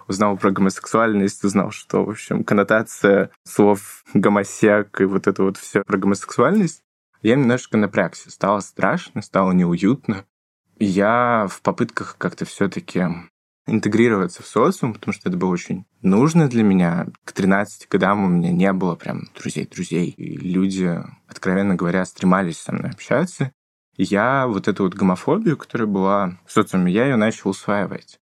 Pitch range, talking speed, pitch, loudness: 95-105 Hz, 150 wpm, 100 Hz, -20 LUFS